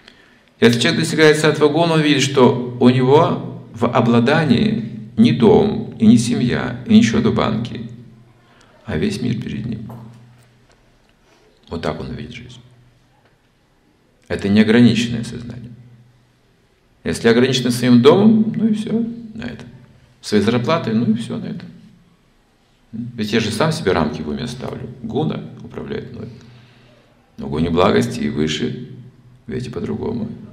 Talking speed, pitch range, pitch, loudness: 135 wpm, 115-135 Hz, 120 Hz, -16 LUFS